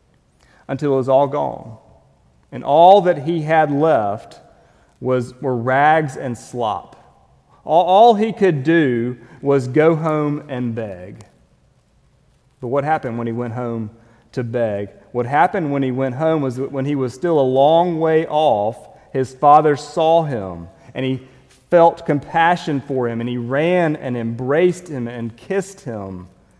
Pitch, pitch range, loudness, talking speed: 135 Hz, 120-160 Hz, -17 LUFS, 160 wpm